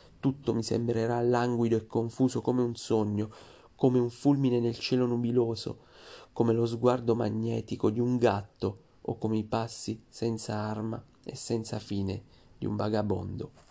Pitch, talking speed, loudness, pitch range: 115 Hz, 150 wpm, -30 LUFS, 110-120 Hz